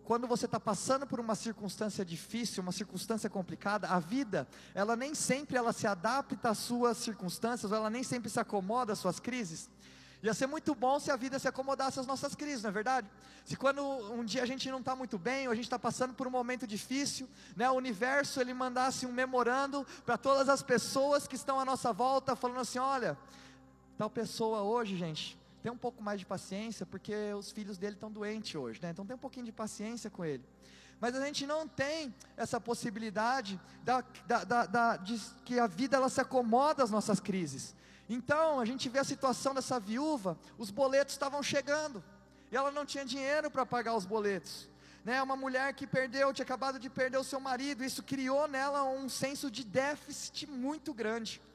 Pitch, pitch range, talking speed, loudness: 250 Hz, 220-270 Hz, 200 wpm, -35 LUFS